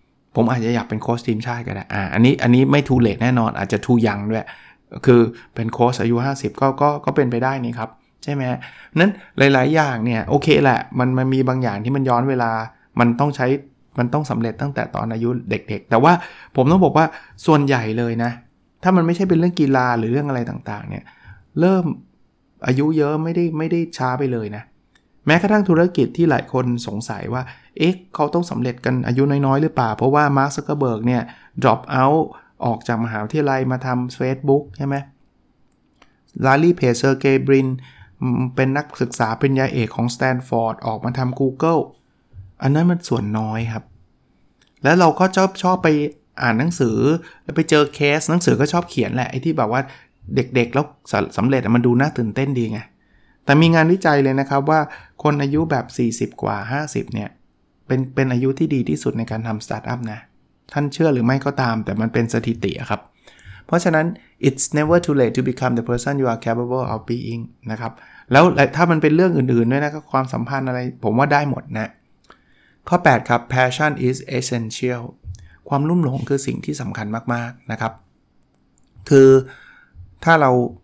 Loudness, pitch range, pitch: -19 LUFS, 115-145 Hz, 130 Hz